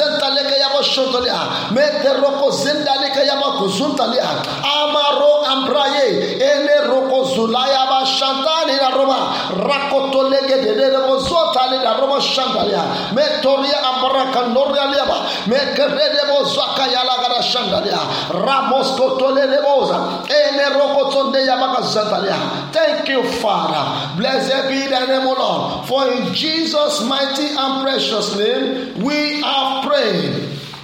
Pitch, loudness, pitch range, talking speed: 270 Hz, -16 LUFS, 260-280 Hz, 115 wpm